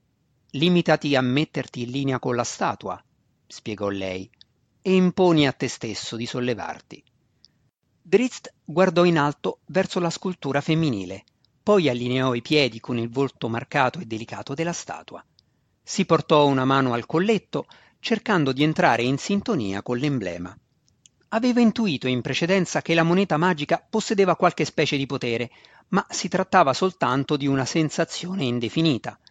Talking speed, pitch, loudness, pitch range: 145 wpm, 145 Hz, -23 LUFS, 125-175 Hz